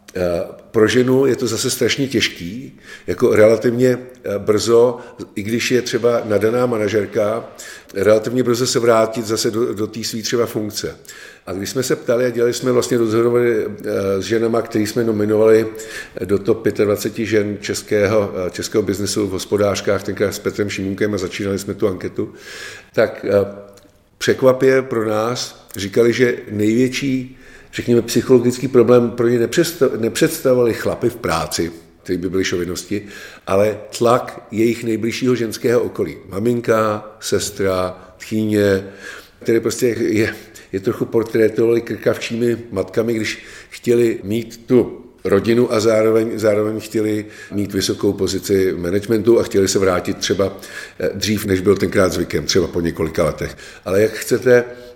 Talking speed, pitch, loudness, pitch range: 140 wpm, 110 Hz, -18 LUFS, 100-120 Hz